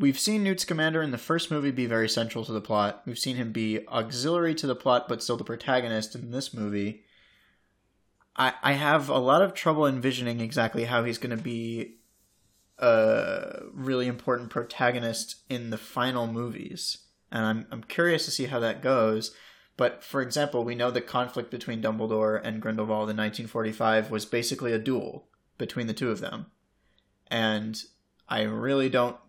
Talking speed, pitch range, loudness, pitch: 180 wpm, 110-130 Hz, -28 LUFS, 120 Hz